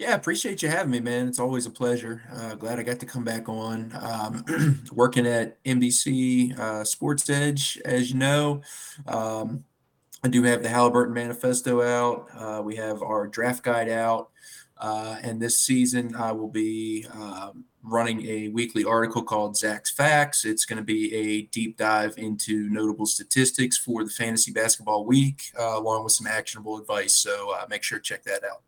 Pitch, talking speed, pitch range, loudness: 115 Hz, 180 wpm, 110-125 Hz, -25 LUFS